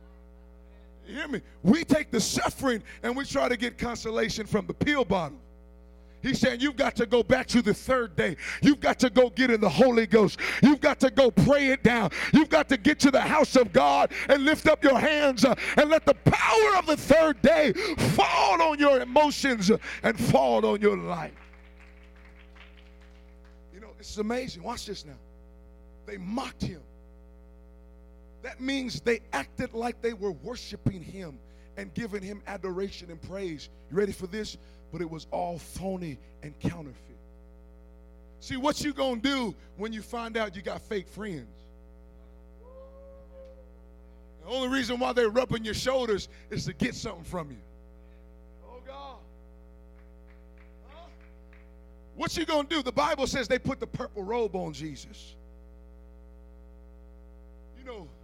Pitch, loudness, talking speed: 190 Hz, -25 LUFS, 165 wpm